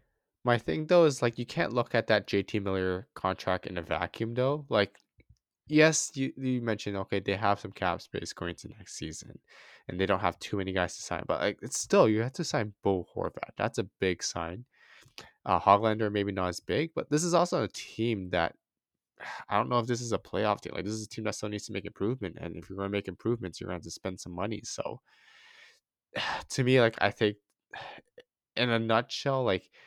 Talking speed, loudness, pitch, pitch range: 225 wpm, -30 LUFS, 105 Hz, 95-125 Hz